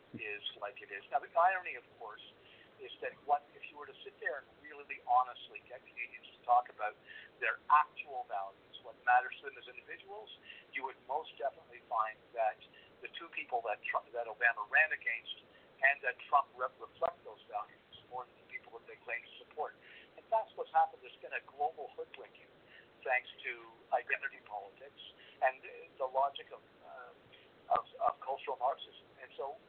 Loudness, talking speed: -36 LUFS, 185 wpm